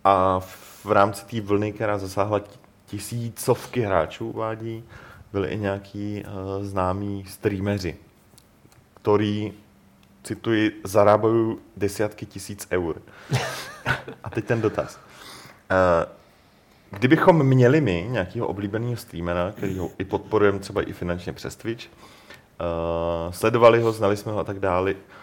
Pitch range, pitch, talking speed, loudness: 95-110 Hz, 100 Hz, 120 wpm, -24 LUFS